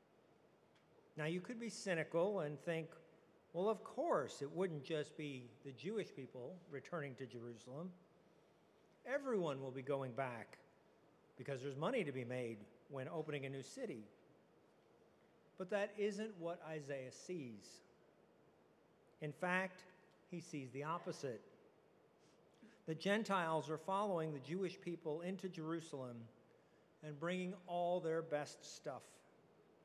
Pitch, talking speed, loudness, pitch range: 160 Hz, 125 wpm, -45 LUFS, 140-185 Hz